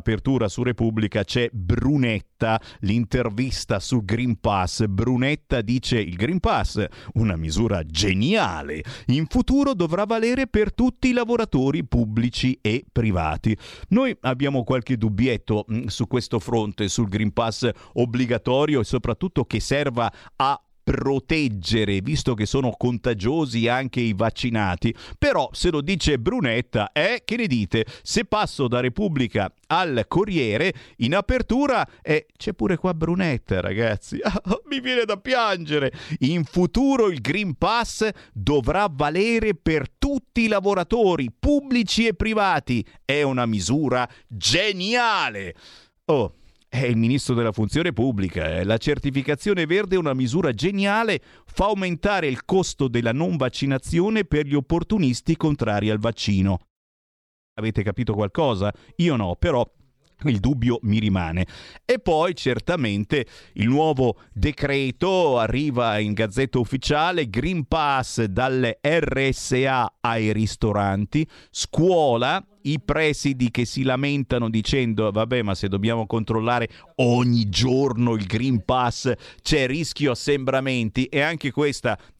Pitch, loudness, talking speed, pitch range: 130 Hz, -22 LUFS, 125 wpm, 115-160 Hz